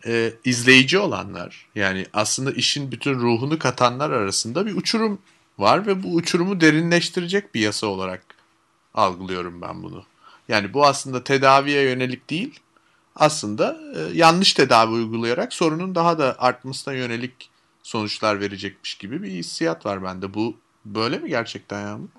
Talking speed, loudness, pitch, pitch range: 140 wpm, -20 LUFS, 125 Hz, 105-160 Hz